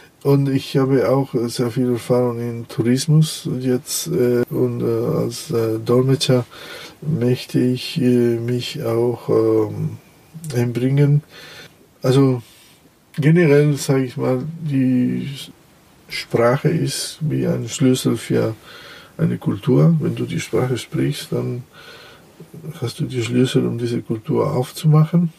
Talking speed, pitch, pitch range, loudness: 110 wpm, 130 Hz, 120-150 Hz, -19 LUFS